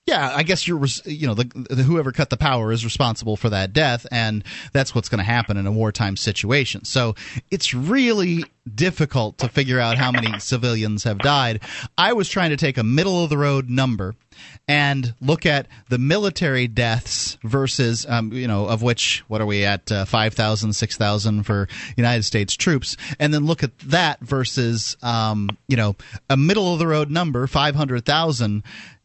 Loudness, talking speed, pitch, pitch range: -20 LUFS, 190 wpm, 125 Hz, 110-145 Hz